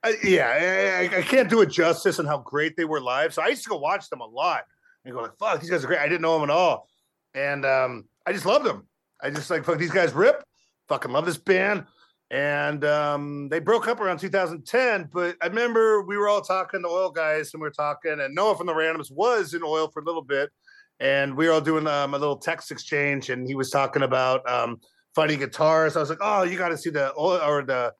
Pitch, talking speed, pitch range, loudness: 160 Hz, 255 wpm, 145-185 Hz, -24 LUFS